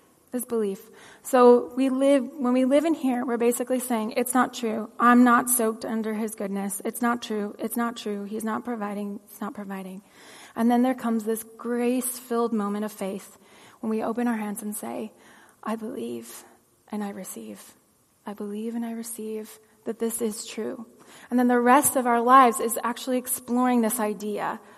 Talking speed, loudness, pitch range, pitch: 185 wpm, -25 LUFS, 210-245 Hz, 230 Hz